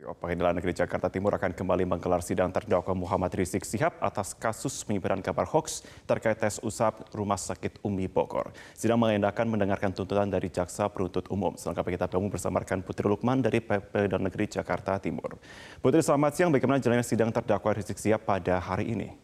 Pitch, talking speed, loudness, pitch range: 100 Hz, 170 wpm, -29 LUFS, 90-110 Hz